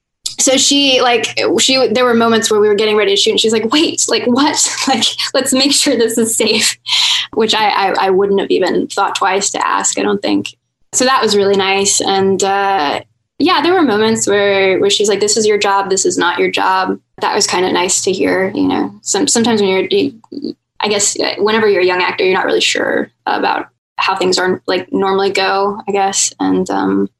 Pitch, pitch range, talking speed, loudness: 215 Hz, 195-265 Hz, 225 wpm, -12 LUFS